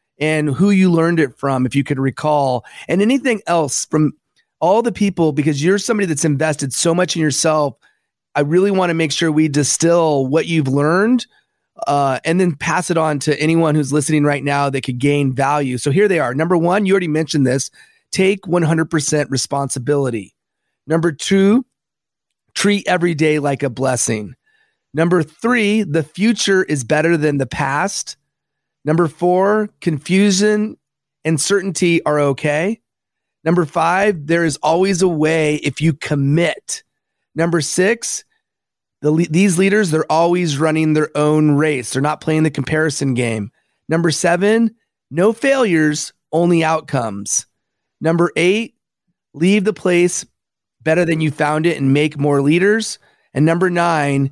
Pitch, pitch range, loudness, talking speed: 160 Hz, 145-180 Hz, -16 LUFS, 155 wpm